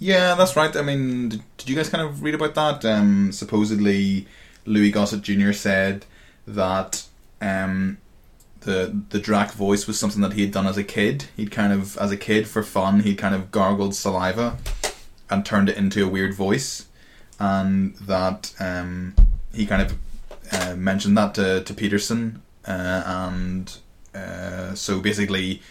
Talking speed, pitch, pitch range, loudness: 165 wpm, 100 Hz, 95-105 Hz, -22 LUFS